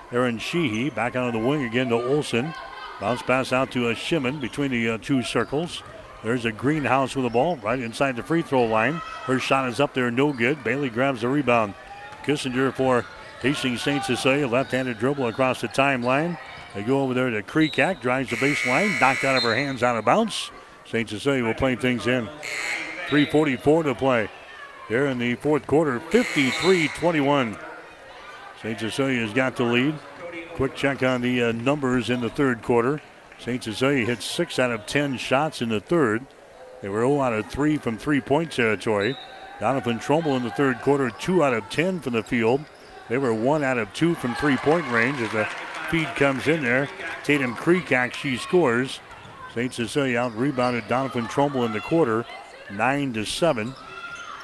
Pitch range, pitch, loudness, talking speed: 120-145 Hz, 130 Hz, -23 LUFS, 180 wpm